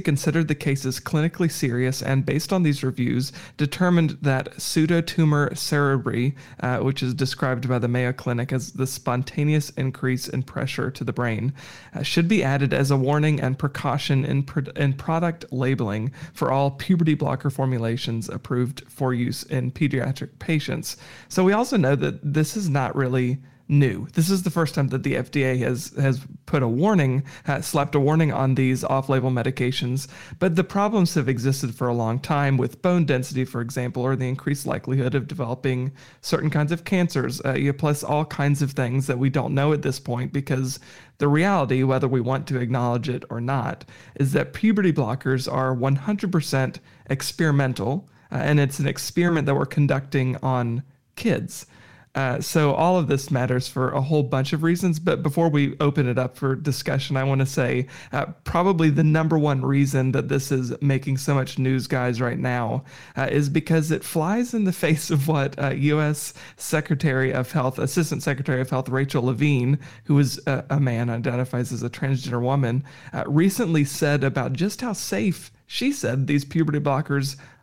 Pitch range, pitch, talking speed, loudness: 130-155 Hz, 140 Hz, 180 wpm, -23 LUFS